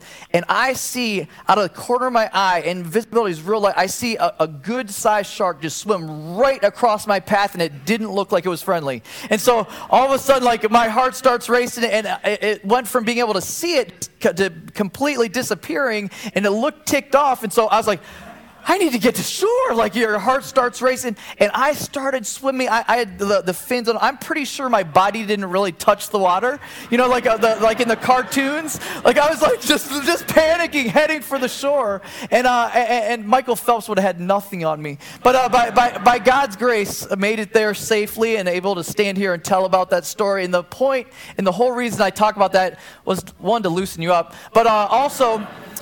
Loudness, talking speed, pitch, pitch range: -18 LUFS, 230 wpm, 225 Hz, 195-255 Hz